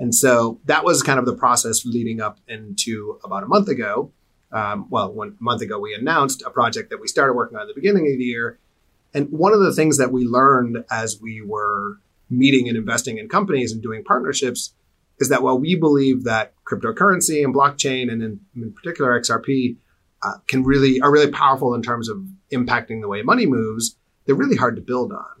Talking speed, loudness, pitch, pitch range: 210 wpm, -19 LUFS, 125 Hz, 115-140 Hz